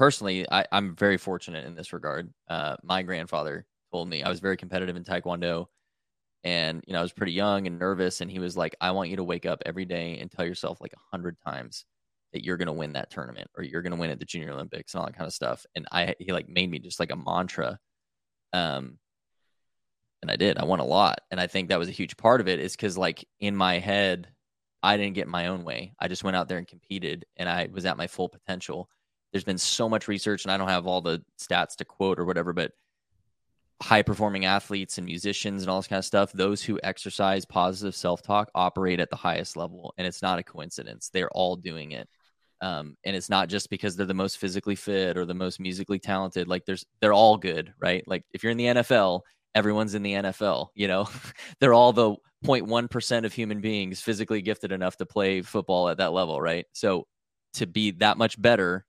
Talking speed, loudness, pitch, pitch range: 230 wpm, -27 LUFS, 95 Hz, 90-100 Hz